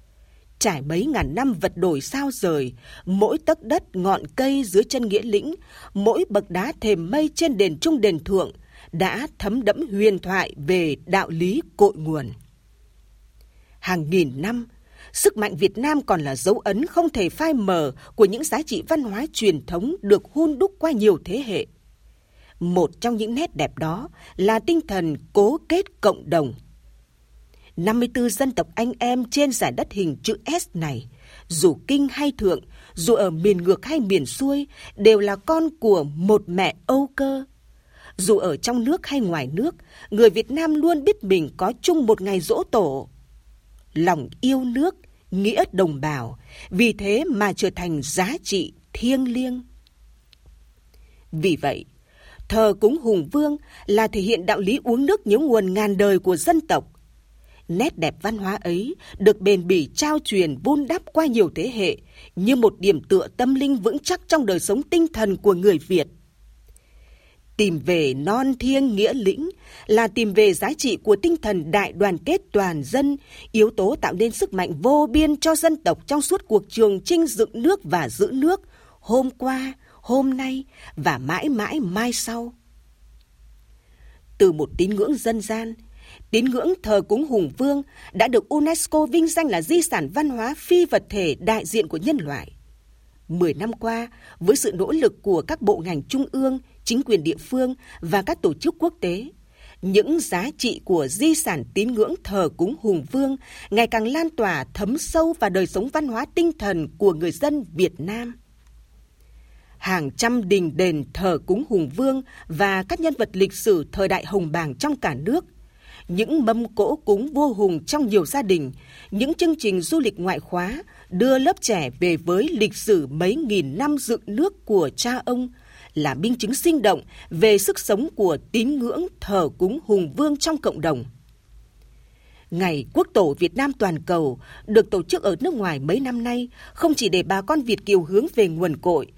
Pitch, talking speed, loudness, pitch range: 215 Hz, 185 wpm, -21 LUFS, 180-280 Hz